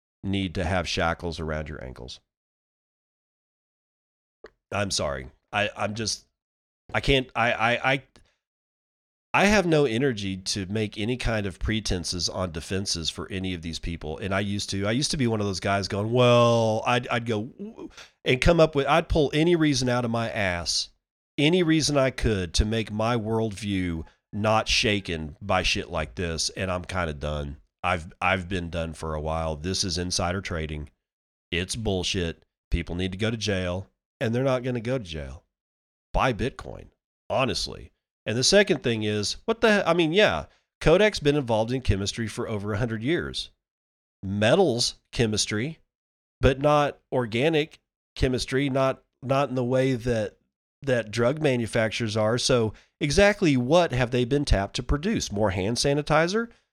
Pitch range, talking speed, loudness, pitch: 90-130 Hz, 170 wpm, -25 LUFS, 105 Hz